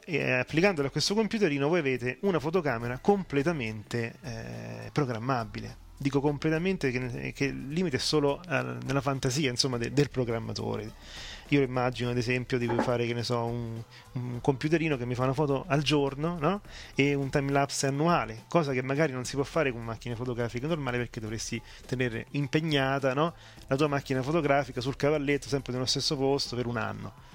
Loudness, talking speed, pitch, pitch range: -29 LUFS, 175 wpm, 135 Hz, 120-145 Hz